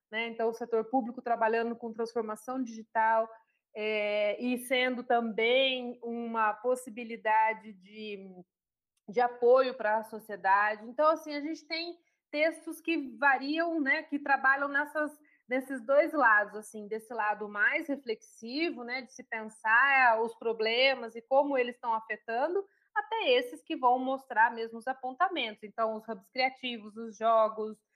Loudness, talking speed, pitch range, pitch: -30 LUFS, 140 wpm, 220-275 Hz, 240 Hz